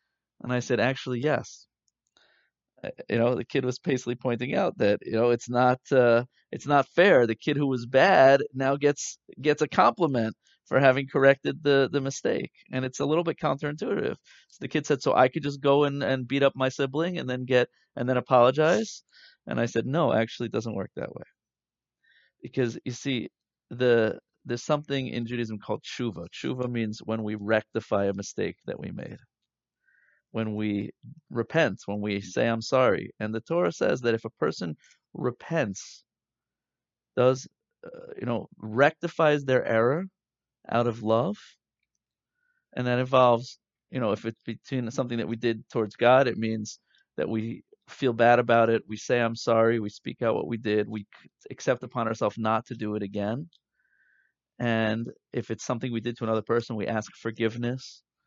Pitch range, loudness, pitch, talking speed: 115-135 Hz, -26 LUFS, 120 Hz, 180 wpm